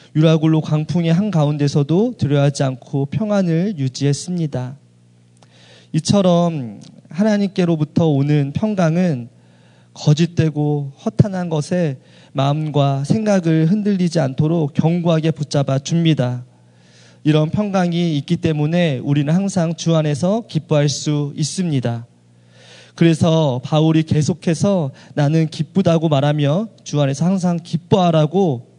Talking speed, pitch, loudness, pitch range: 275 characters per minute, 155 Hz, -17 LUFS, 140-170 Hz